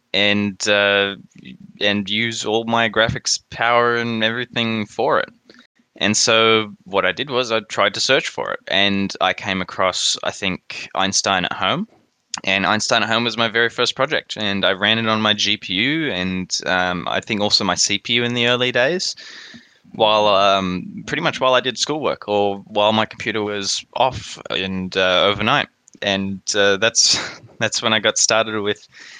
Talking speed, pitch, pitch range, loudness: 175 wpm, 105 Hz, 100-115 Hz, -18 LUFS